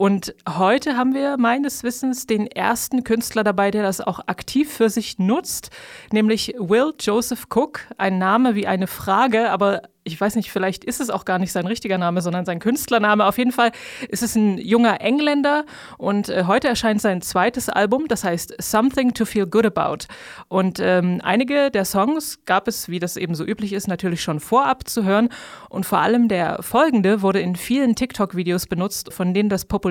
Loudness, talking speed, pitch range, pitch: -20 LUFS, 190 wpm, 190-245 Hz, 215 Hz